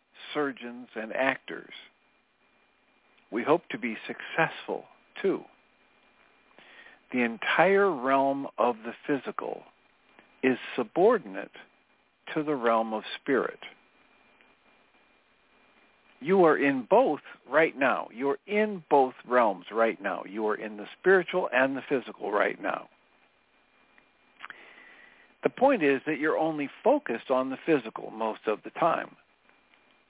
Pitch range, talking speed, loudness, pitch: 115-155 Hz, 115 wpm, -28 LUFS, 135 Hz